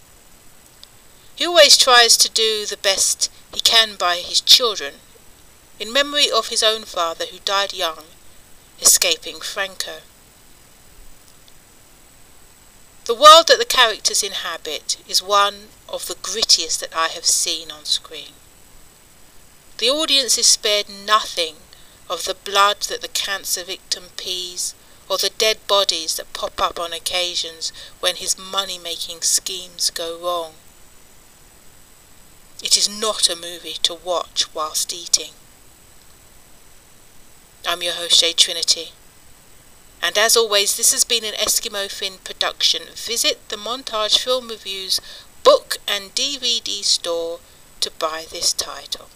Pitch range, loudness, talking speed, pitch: 175-230 Hz, -17 LUFS, 130 wpm, 200 Hz